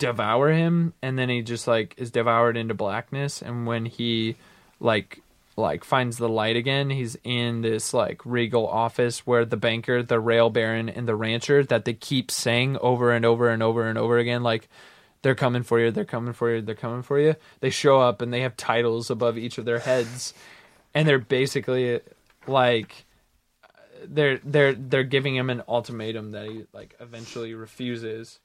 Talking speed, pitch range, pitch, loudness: 185 wpm, 115-130 Hz, 120 Hz, -24 LUFS